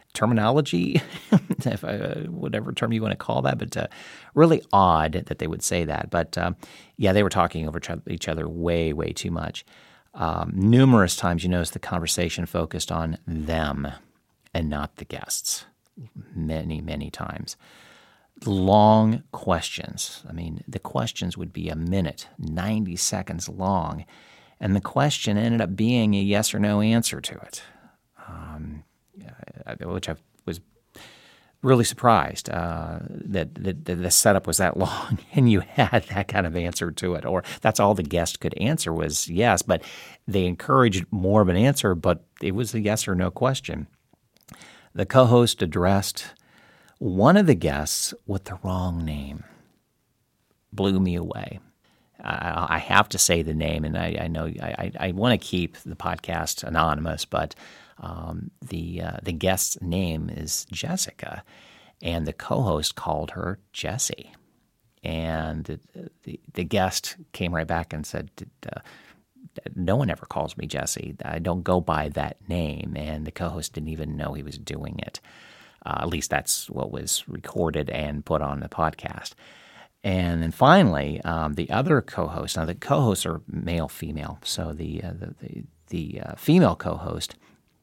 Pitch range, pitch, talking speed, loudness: 80-100 Hz, 90 Hz, 165 wpm, -24 LUFS